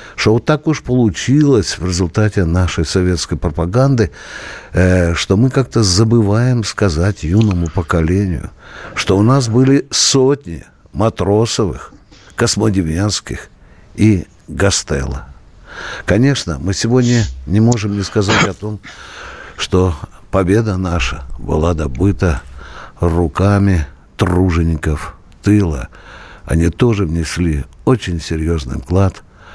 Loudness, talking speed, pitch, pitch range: -15 LUFS, 100 wpm, 95 Hz, 85-110 Hz